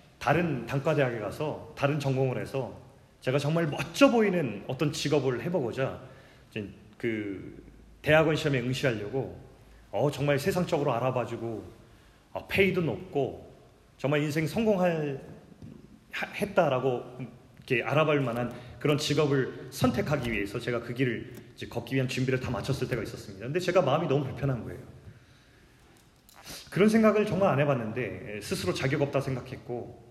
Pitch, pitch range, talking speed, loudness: 135 Hz, 120-150 Hz, 325 characters per minute, -29 LUFS